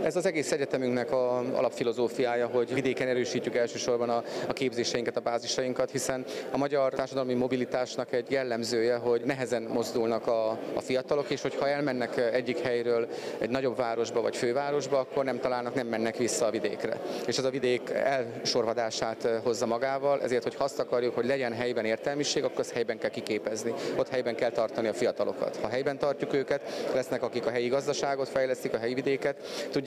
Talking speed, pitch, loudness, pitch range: 165 wpm, 125 Hz, -30 LUFS, 120-135 Hz